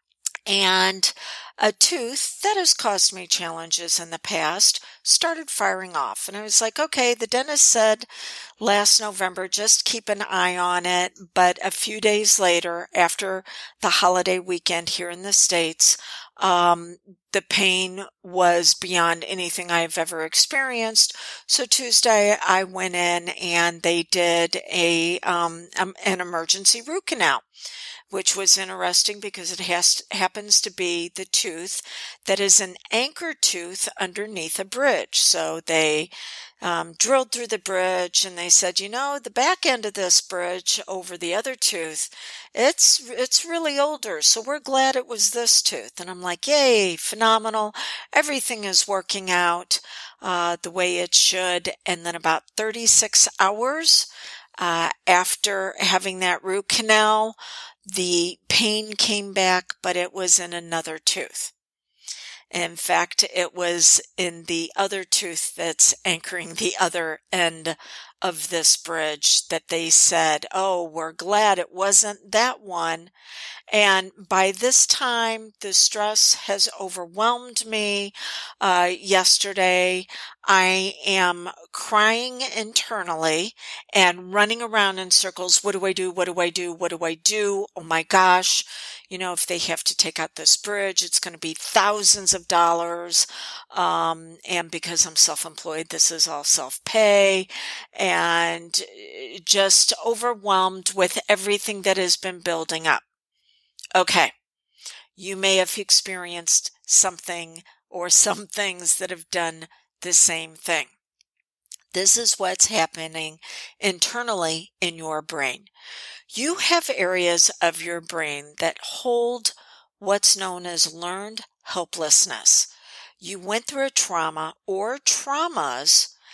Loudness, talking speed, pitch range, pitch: -20 LUFS, 140 wpm, 175-215 Hz, 185 Hz